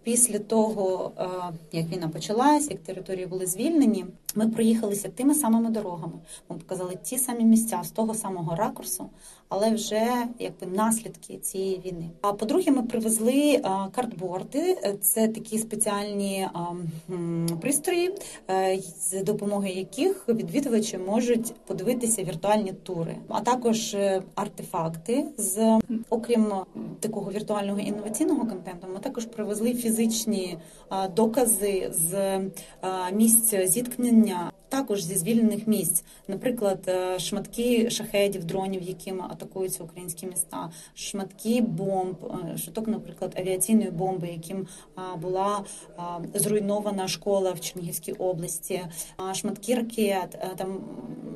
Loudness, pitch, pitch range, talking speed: -26 LUFS, 200 Hz, 185-225 Hz, 105 wpm